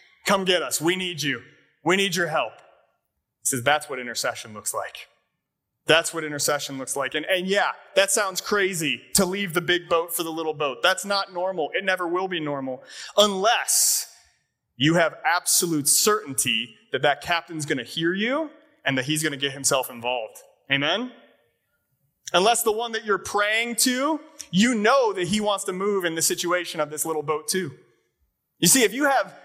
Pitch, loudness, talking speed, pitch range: 175 Hz, -23 LUFS, 190 wpm, 150-195 Hz